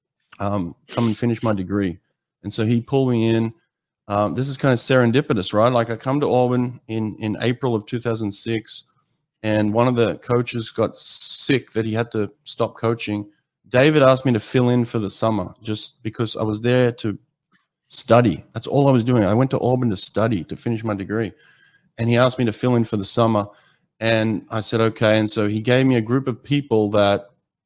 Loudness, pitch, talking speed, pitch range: -20 LUFS, 115 Hz, 210 wpm, 110-125 Hz